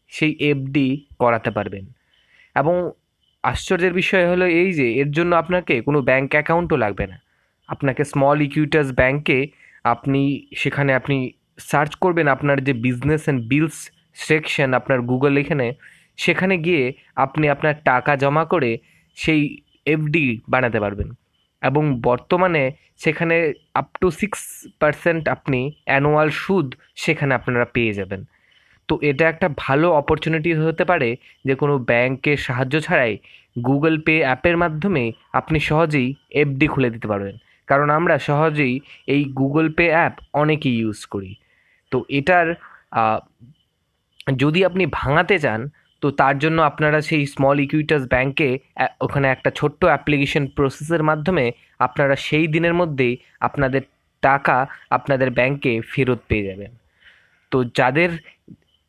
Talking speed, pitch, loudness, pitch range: 130 wpm, 145 Hz, -19 LUFS, 130-160 Hz